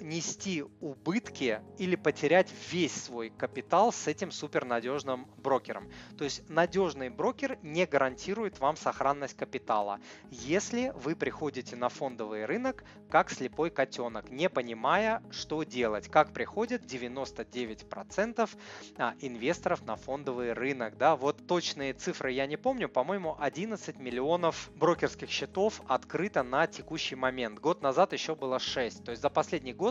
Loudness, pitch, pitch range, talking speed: -32 LUFS, 150 Hz, 130-180 Hz, 130 wpm